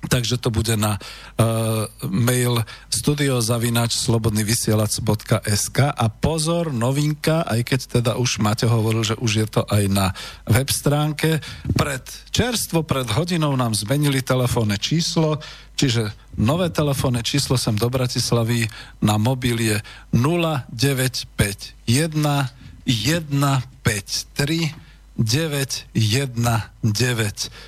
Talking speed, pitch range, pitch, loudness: 100 wpm, 115-140 Hz, 125 Hz, -21 LUFS